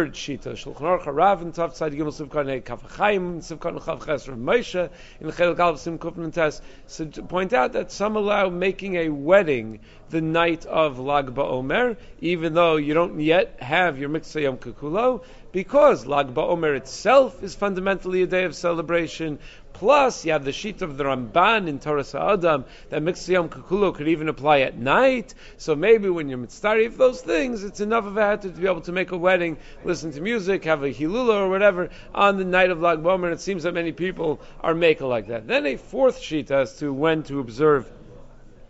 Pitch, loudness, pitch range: 170 Hz, -22 LUFS, 150-190 Hz